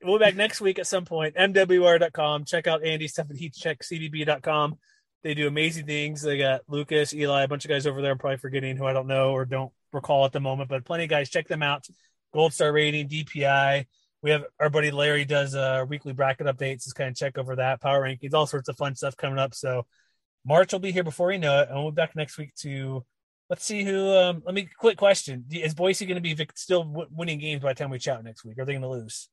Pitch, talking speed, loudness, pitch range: 150 Hz, 250 wpm, -25 LUFS, 135-165 Hz